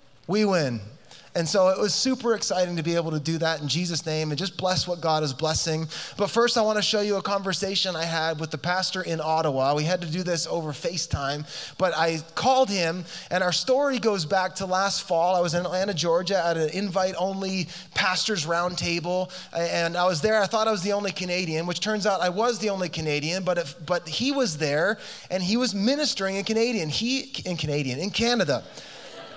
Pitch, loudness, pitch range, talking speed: 180 Hz, -25 LUFS, 165-200 Hz, 220 wpm